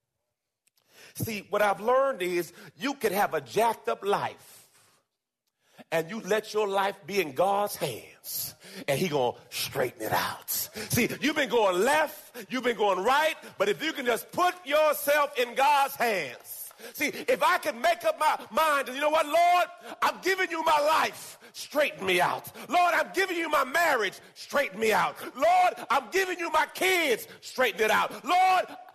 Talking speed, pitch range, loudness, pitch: 180 wpm, 215-335 Hz, -27 LUFS, 285 Hz